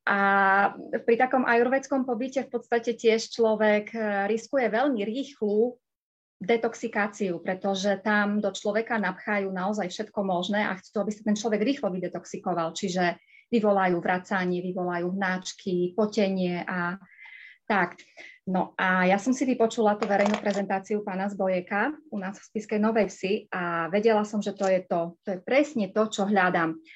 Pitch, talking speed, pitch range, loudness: 205 Hz, 150 wpm, 185-225 Hz, -26 LUFS